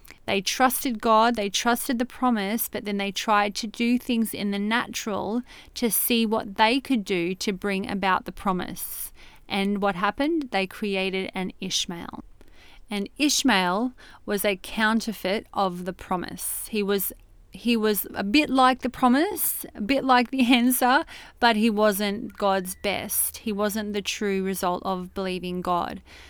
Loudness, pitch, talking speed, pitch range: -24 LUFS, 210 Hz, 160 wpm, 195-245 Hz